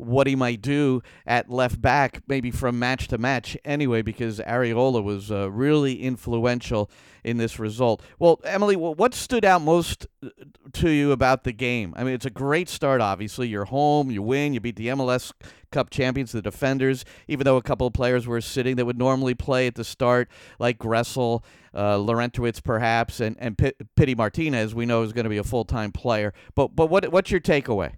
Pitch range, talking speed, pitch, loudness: 115-135 Hz, 200 wpm, 125 Hz, -23 LUFS